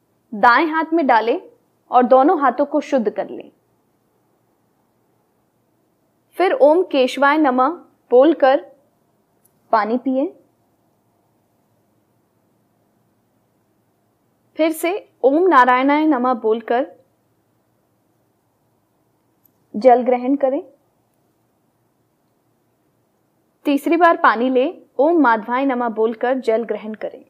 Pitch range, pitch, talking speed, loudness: 230-295 Hz, 260 Hz, 85 wpm, -17 LUFS